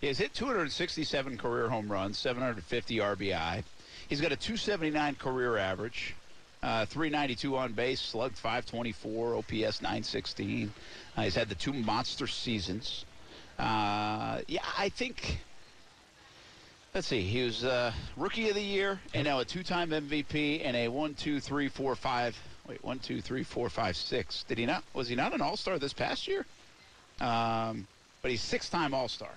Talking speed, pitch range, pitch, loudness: 160 wpm, 110-150 Hz, 125 Hz, -33 LUFS